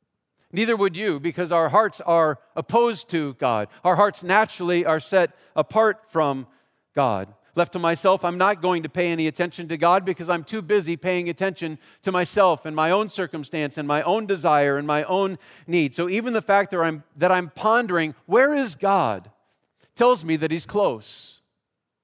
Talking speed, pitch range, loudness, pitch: 180 wpm, 160-195 Hz, -22 LUFS, 175 Hz